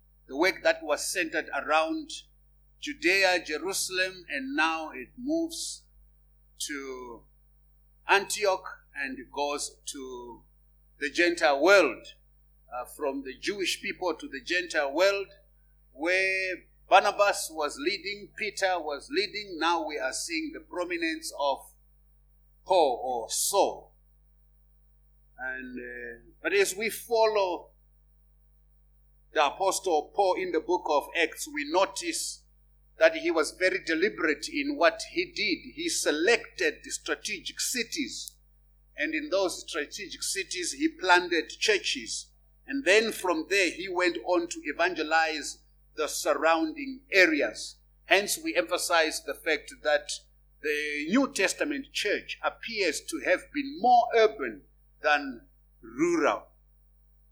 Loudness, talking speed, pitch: -28 LUFS, 120 wpm, 175 Hz